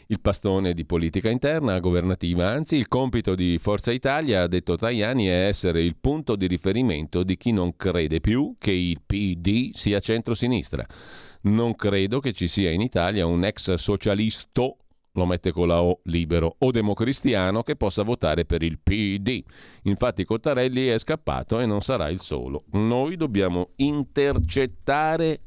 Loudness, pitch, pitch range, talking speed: -24 LUFS, 100 Hz, 90-120 Hz, 160 wpm